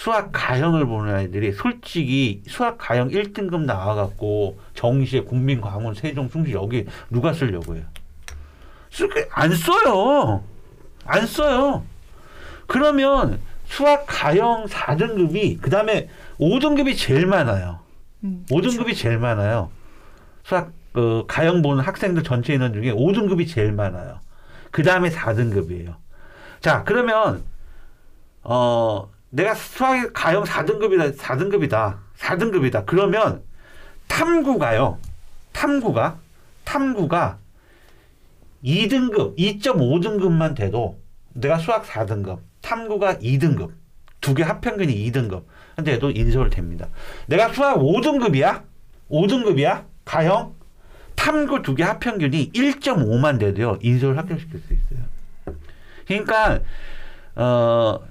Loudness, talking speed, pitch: -20 LUFS, 235 characters per minute, 135 Hz